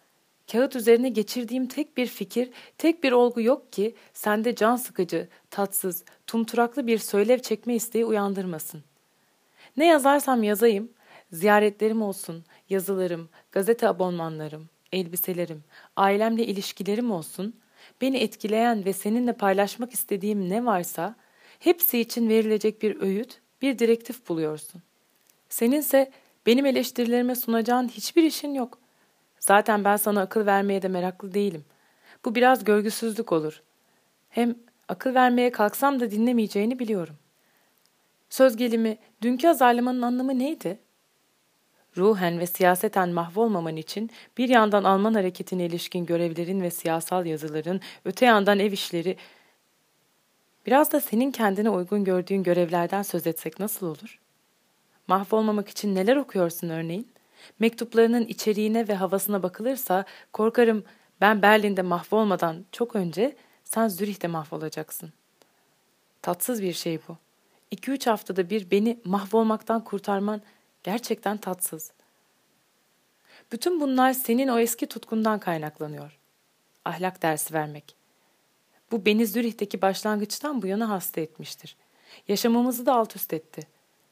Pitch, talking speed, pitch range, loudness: 210 Hz, 120 wpm, 185-235 Hz, -25 LUFS